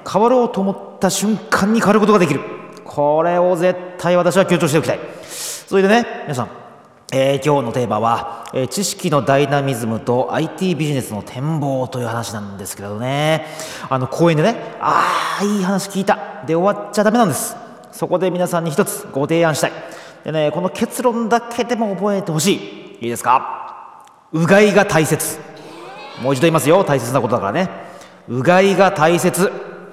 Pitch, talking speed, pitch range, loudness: 170 Hz, 350 characters per minute, 140-200 Hz, -17 LUFS